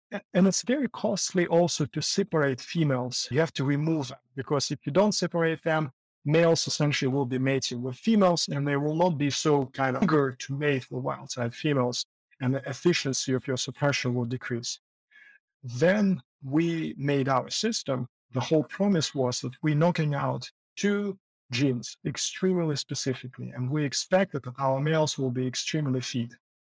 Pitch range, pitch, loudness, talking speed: 130-170 Hz, 145 Hz, -27 LUFS, 170 wpm